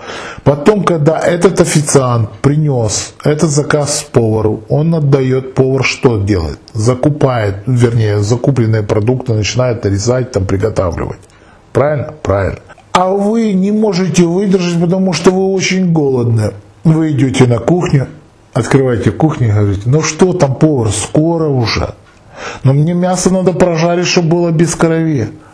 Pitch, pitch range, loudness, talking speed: 140 Hz, 115-170 Hz, -12 LUFS, 130 wpm